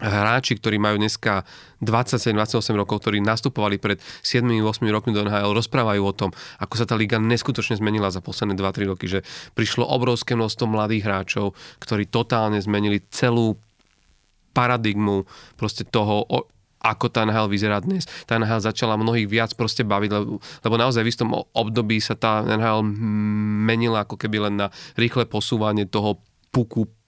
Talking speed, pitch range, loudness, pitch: 155 wpm, 105-115 Hz, -22 LUFS, 110 Hz